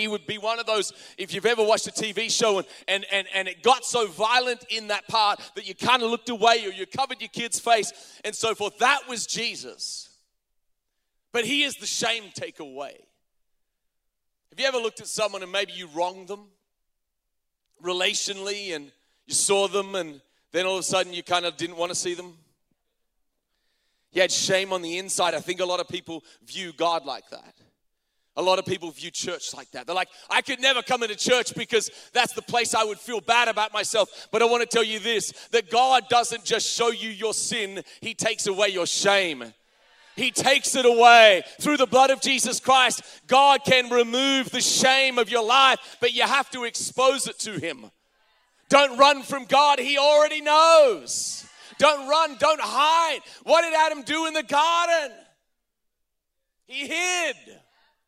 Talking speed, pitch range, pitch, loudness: 190 wpm, 190-265 Hz, 225 Hz, -22 LUFS